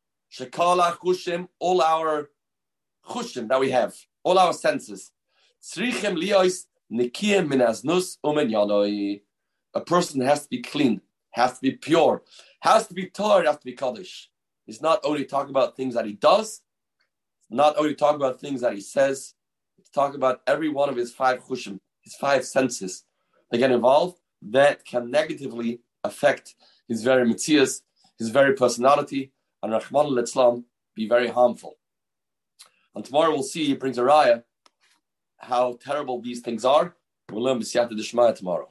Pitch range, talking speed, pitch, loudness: 120-150 Hz, 150 wpm, 135 Hz, -23 LUFS